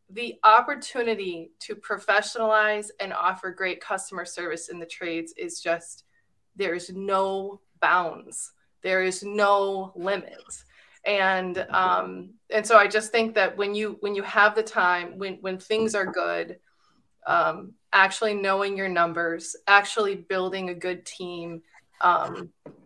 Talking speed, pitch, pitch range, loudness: 140 wpm, 195 Hz, 180-210 Hz, -24 LUFS